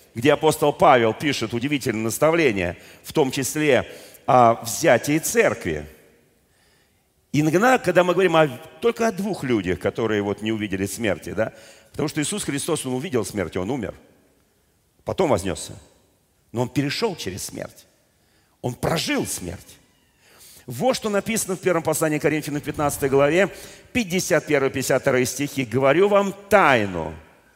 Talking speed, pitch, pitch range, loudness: 135 wpm, 145 Hz, 120-180 Hz, -21 LUFS